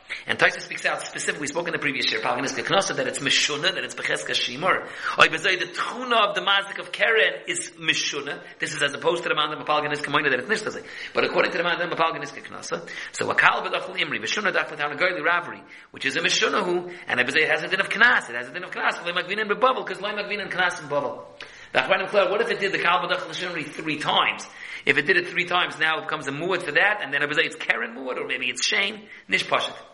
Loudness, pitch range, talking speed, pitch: -23 LUFS, 155-205 Hz, 255 wpm, 180 Hz